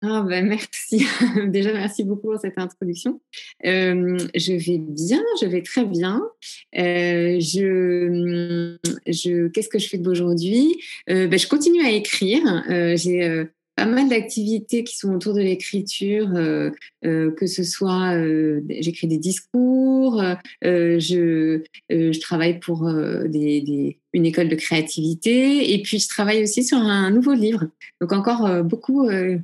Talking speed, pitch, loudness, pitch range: 160 wpm, 185 Hz, -20 LUFS, 170-215 Hz